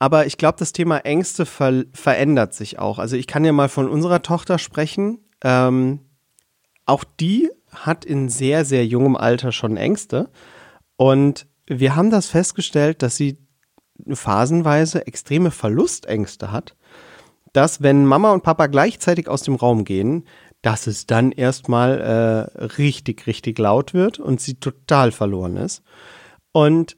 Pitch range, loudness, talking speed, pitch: 120-160 Hz, -18 LUFS, 145 wpm, 140 Hz